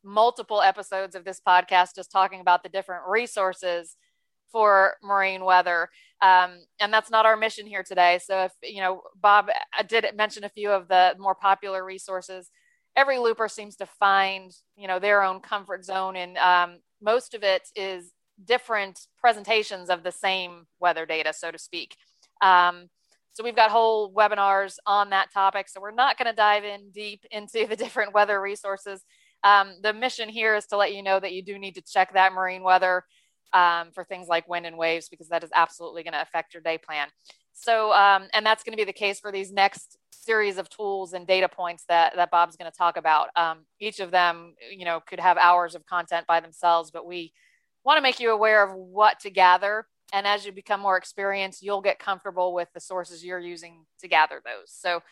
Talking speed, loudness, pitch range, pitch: 205 wpm, -23 LUFS, 180-210 Hz, 195 Hz